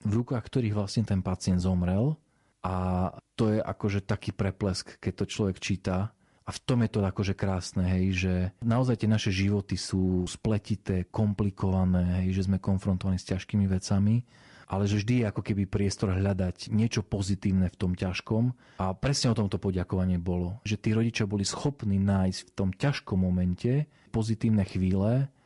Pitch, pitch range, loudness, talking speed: 100 Hz, 95-110 Hz, -29 LUFS, 165 wpm